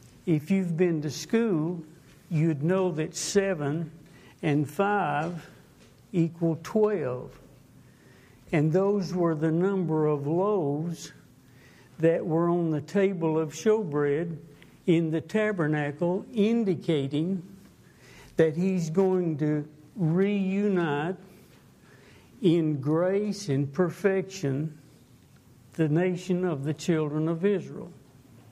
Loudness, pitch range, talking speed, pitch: -27 LUFS, 150-190 Hz, 100 wpm, 165 Hz